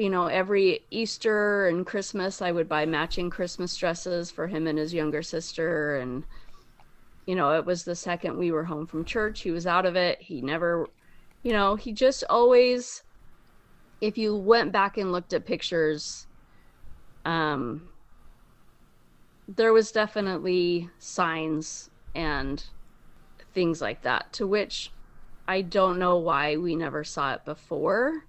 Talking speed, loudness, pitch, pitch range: 150 wpm, -26 LUFS, 175 Hz, 160-200 Hz